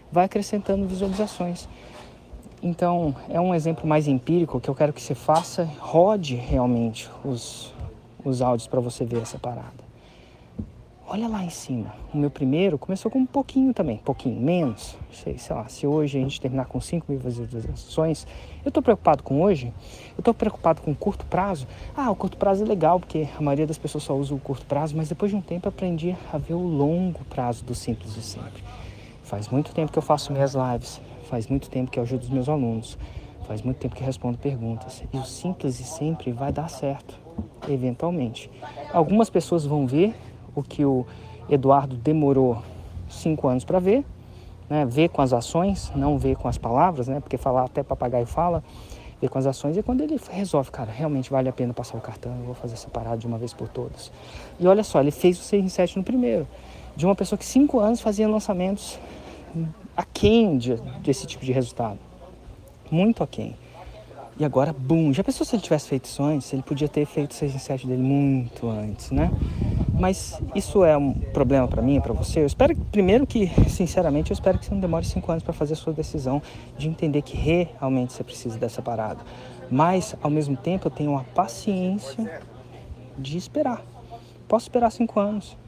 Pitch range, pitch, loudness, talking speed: 125-175 Hz, 140 Hz, -24 LUFS, 195 wpm